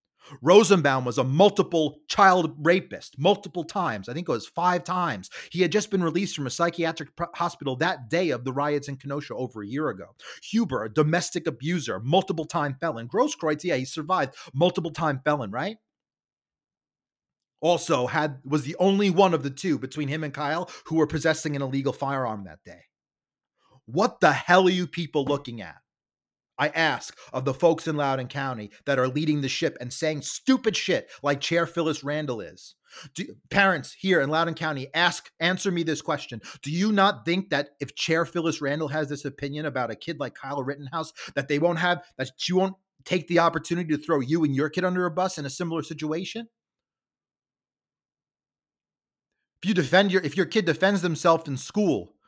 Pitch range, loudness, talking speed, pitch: 140-180 Hz, -25 LUFS, 185 wpm, 160 Hz